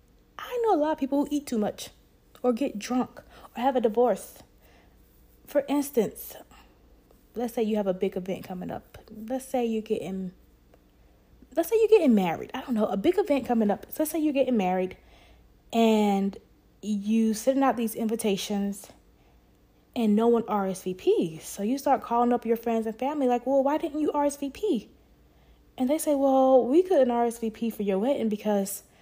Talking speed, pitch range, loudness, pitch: 180 wpm, 200-275 Hz, -26 LUFS, 235 Hz